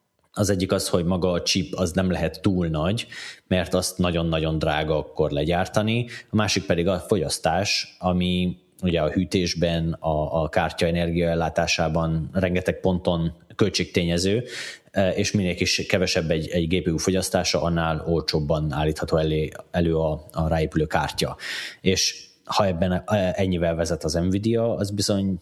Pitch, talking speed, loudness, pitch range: 90 Hz, 140 wpm, -23 LUFS, 80-95 Hz